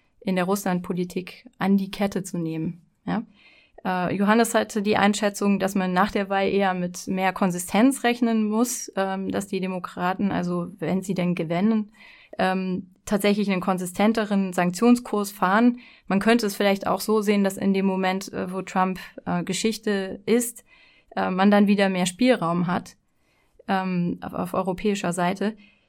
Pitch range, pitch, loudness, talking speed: 185-215 Hz, 195 Hz, -24 LUFS, 140 wpm